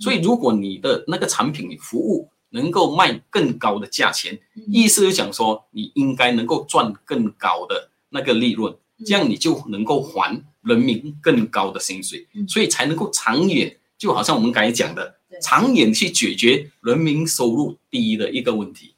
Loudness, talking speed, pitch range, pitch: -19 LUFS, 260 characters per minute, 140-235 Hz, 195 Hz